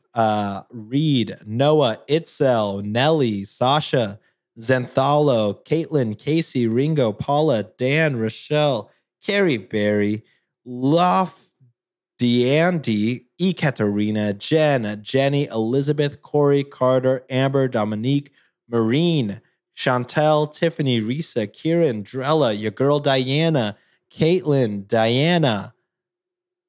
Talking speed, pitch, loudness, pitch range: 80 wpm, 135 Hz, -20 LUFS, 115-155 Hz